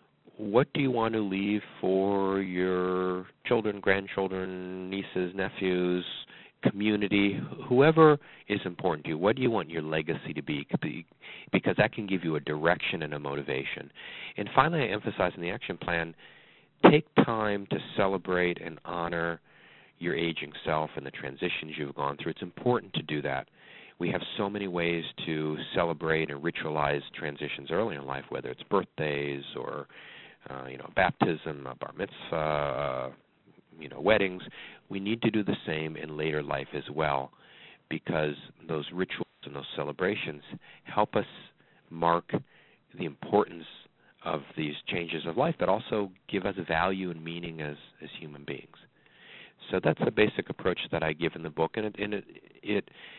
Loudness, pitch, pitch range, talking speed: -30 LUFS, 85 Hz, 75-100 Hz, 165 wpm